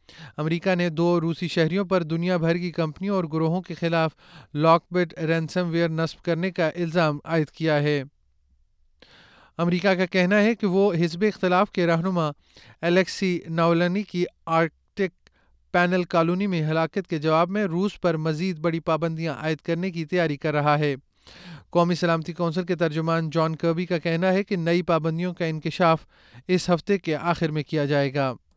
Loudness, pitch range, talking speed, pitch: -24 LUFS, 160-180 Hz, 170 wpm, 170 Hz